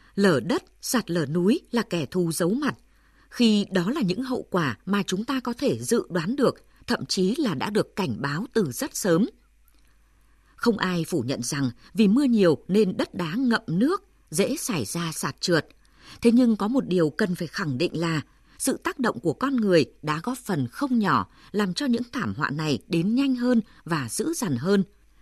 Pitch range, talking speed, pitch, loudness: 170-245 Hz, 205 wpm, 195 Hz, -25 LUFS